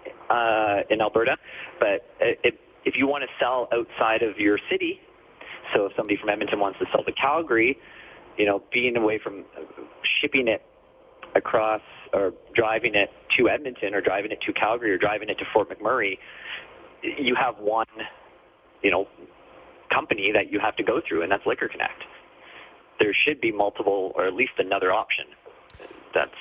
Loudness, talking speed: -24 LUFS, 170 wpm